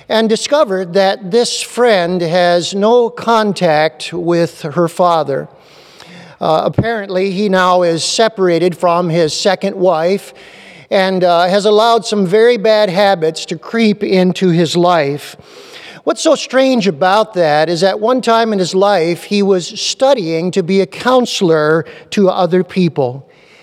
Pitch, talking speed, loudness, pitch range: 190 Hz, 140 wpm, -13 LUFS, 175-220 Hz